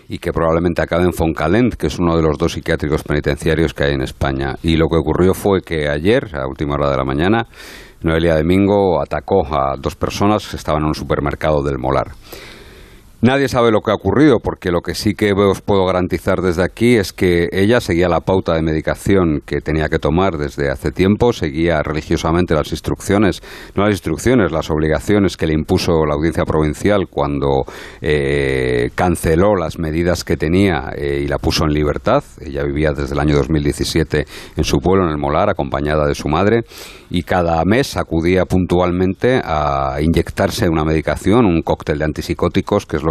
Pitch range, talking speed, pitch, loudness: 75-95 Hz, 190 wpm, 80 Hz, -16 LUFS